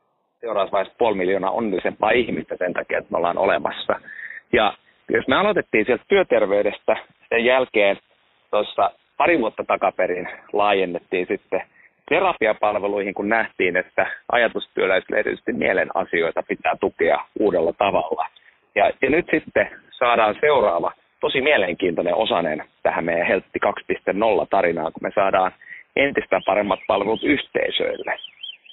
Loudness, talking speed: -21 LUFS, 120 wpm